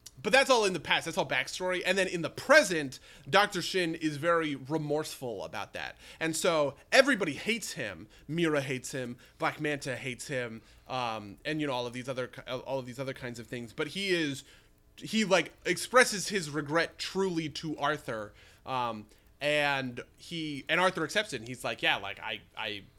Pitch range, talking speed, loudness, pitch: 130-175 Hz, 190 wpm, -30 LUFS, 150 Hz